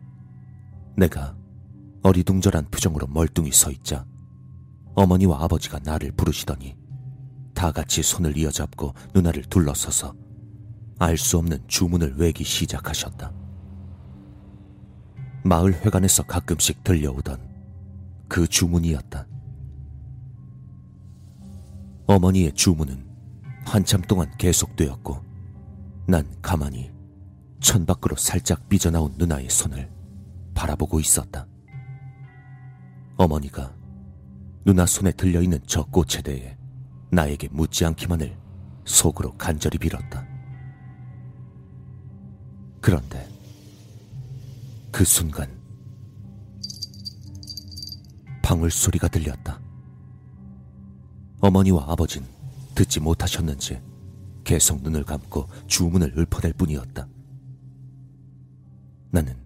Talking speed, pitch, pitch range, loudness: 205 characters per minute, 95 Hz, 75-105 Hz, -22 LUFS